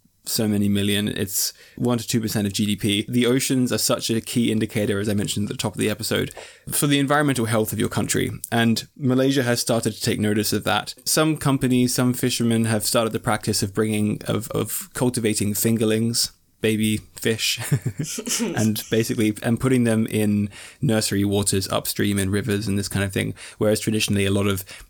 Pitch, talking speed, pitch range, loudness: 110 Hz, 190 wpm, 105-125 Hz, -22 LUFS